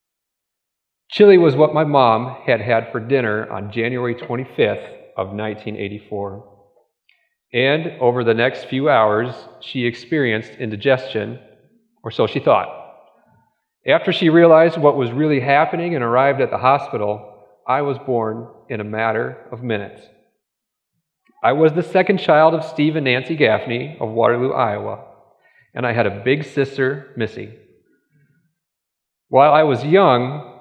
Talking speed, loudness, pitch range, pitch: 140 wpm, -17 LUFS, 115-155 Hz, 130 Hz